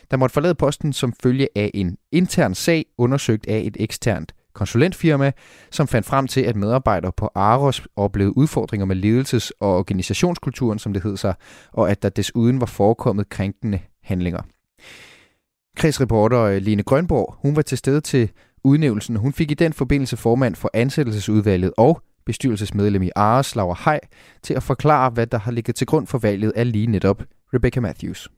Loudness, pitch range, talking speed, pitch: -20 LUFS, 105-135 Hz, 170 wpm, 115 Hz